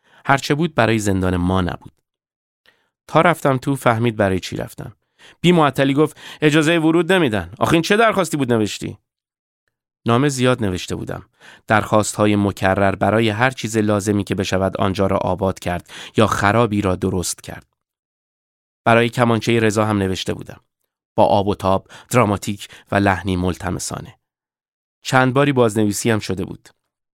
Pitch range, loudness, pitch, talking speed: 95-130 Hz, -18 LUFS, 110 Hz, 145 wpm